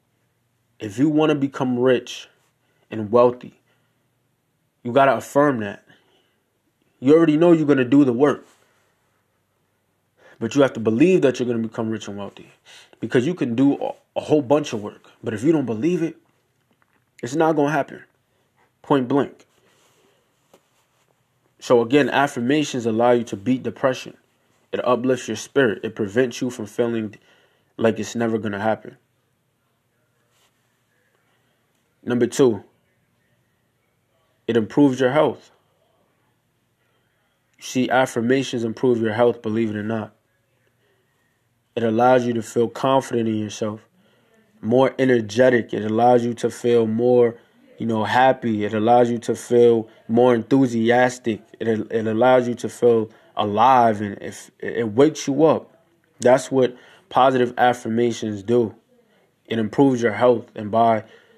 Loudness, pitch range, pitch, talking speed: -20 LUFS, 115-130 Hz, 120 Hz, 140 wpm